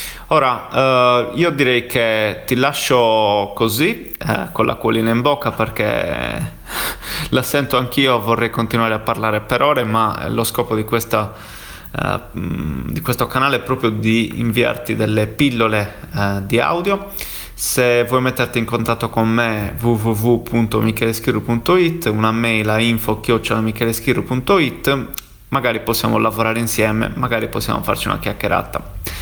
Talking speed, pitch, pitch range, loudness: 130 wpm, 115 Hz, 110-125 Hz, -17 LUFS